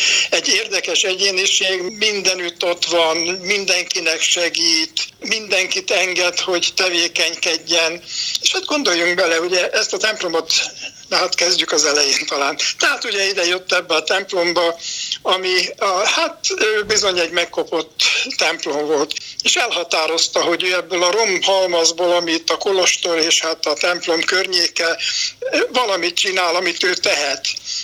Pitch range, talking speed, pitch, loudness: 170-195 Hz, 130 wpm, 180 Hz, -16 LUFS